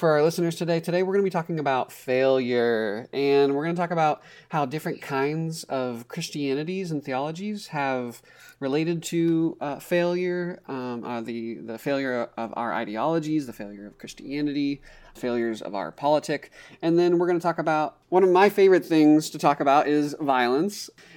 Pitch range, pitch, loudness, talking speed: 130-170 Hz, 150 Hz, -25 LUFS, 180 wpm